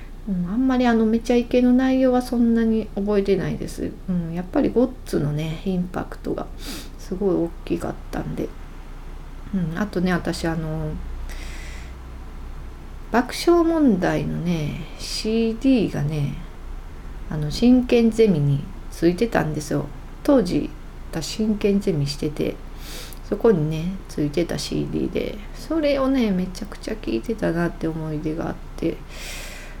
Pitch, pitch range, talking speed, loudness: 180 Hz, 150-230 Hz, 260 characters per minute, -22 LUFS